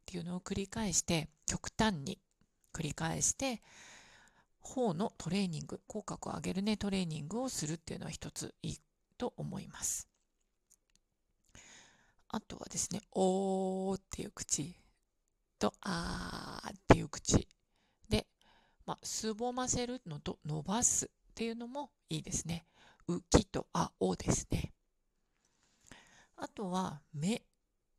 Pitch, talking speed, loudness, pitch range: 190 Hz, 240 characters per minute, -37 LUFS, 170-225 Hz